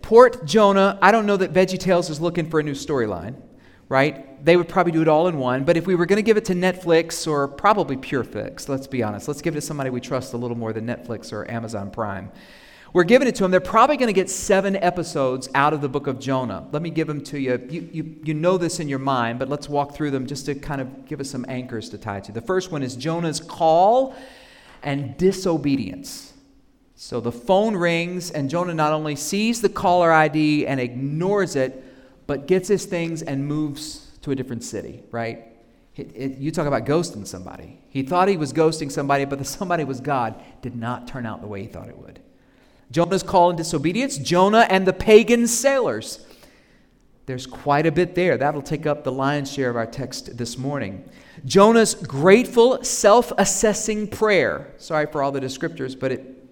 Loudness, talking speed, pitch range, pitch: -21 LUFS, 215 wpm, 130-180 Hz, 150 Hz